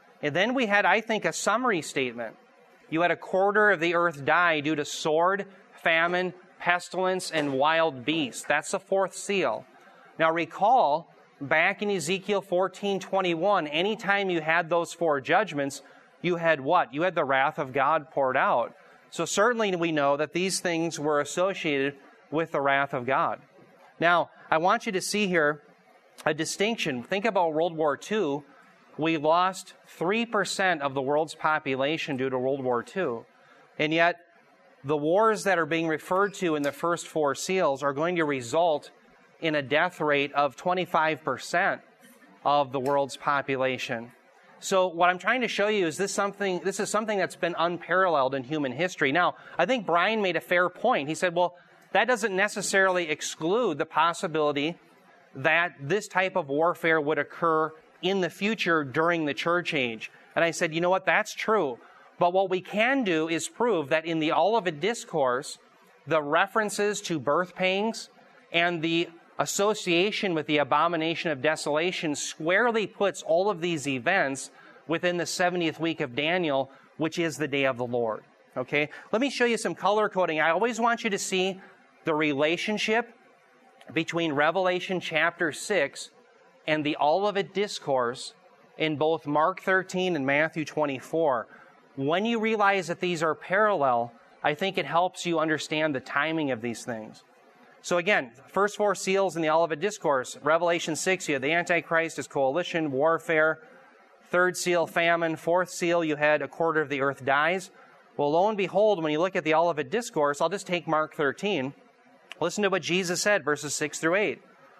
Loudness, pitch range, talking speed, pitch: -26 LUFS, 150-190 Hz, 170 wpm, 170 Hz